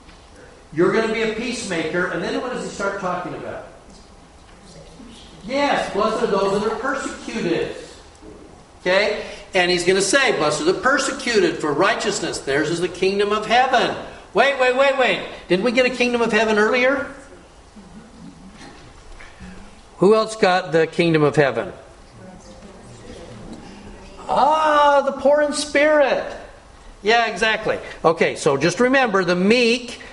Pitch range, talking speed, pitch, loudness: 190-265 Hz, 140 wpm, 225 Hz, -19 LUFS